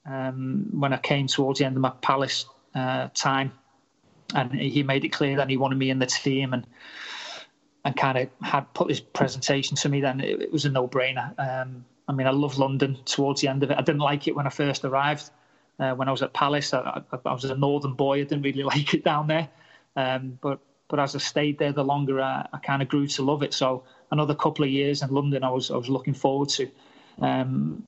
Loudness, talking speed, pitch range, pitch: -26 LUFS, 240 wpm, 135-145 Hz, 140 Hz